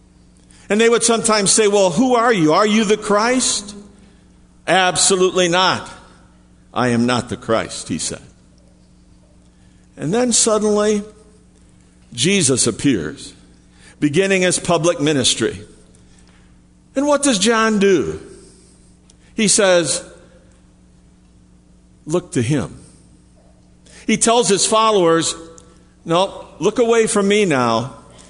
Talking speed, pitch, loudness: 110 wpm, 155 Hz, -16 LUFS